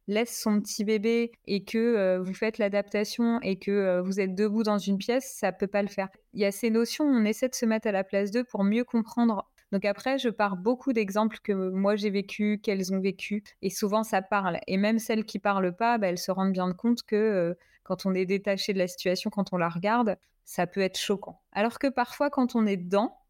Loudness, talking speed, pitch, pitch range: -28 LUFS, 240 wpm, 210 Hz, 195-230 Hz